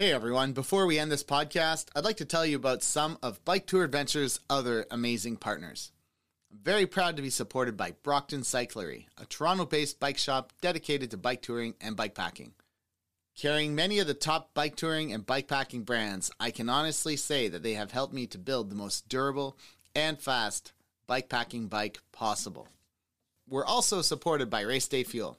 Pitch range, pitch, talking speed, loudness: 115-150 Hz, 135 Hz, 190 wpm, -31 LUFS